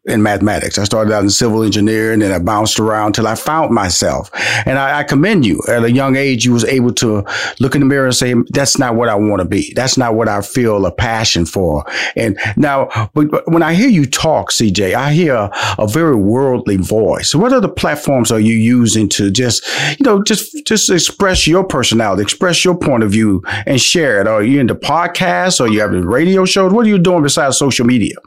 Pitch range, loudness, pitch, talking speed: 105-155 Hz, -12 LUFS, 120 Hz, 225 wpm